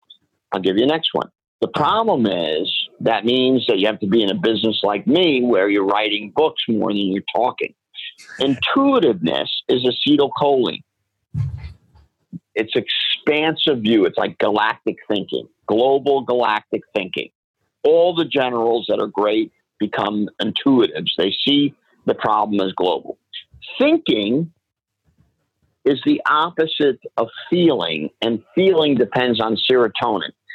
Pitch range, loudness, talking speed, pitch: 110-155 Hz, -18 LUFS, 130 wpm, 125 Hz